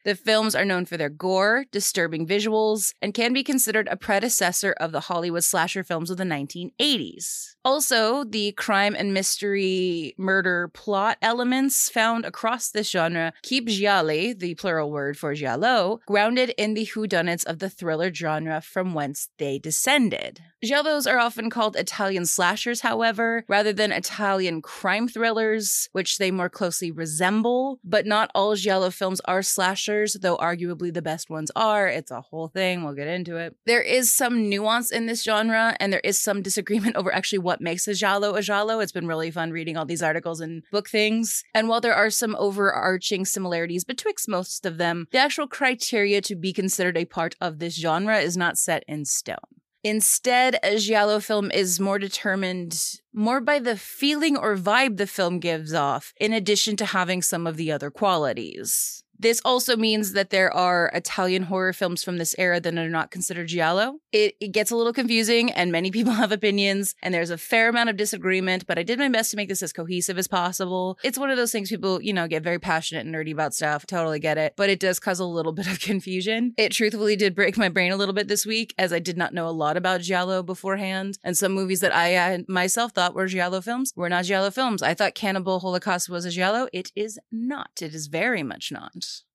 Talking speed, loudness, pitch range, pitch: 200 wpm, -23 LUFS, 175-220 Hz, 195 Hz